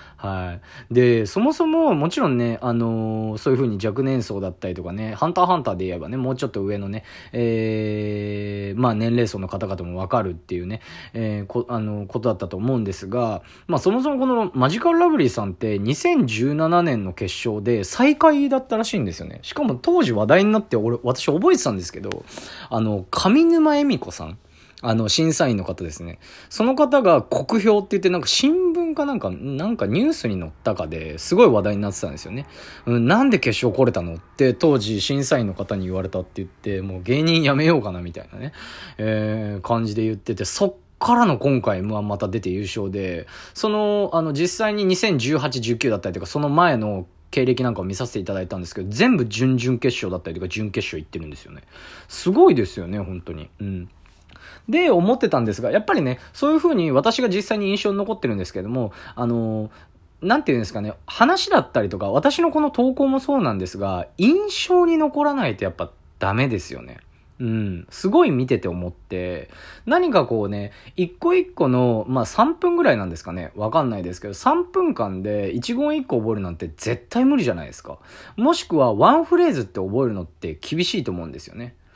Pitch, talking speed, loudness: 120 Hz, 400 characters per minute, -21 LUFS